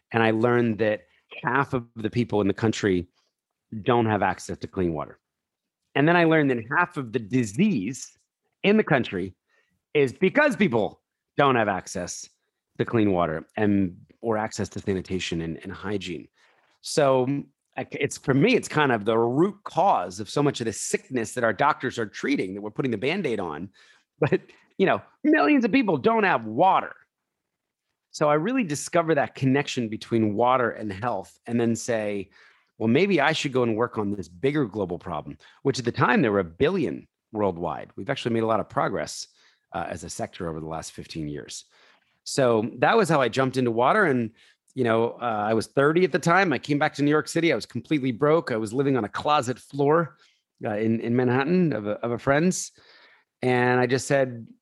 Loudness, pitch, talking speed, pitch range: -24 LUFS, 125 Hz, 200 wpm, 110-150 Hz